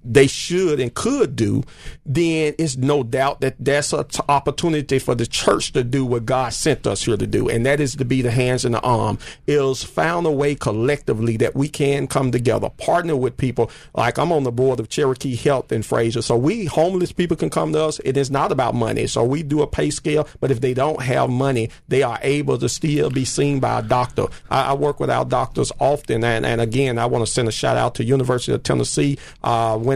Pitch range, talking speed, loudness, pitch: 120-145 Hz, 235 wpm, -20 LUFS, 135 Hz